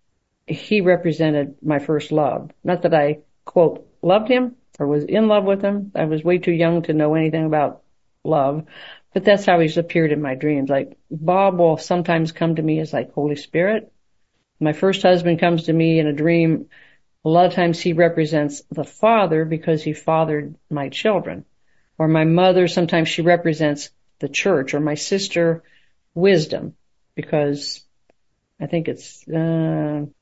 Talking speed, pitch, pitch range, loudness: 170 wpm, 160 Hz, 150-175 Hz, -19 LUFS